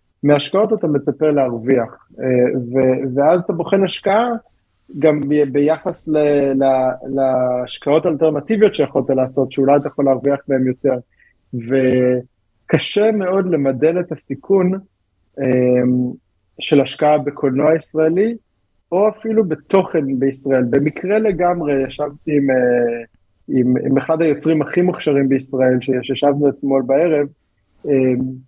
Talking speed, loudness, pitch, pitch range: 110 wpm, -17 LUFS, 140 Hz, 130-160 Hz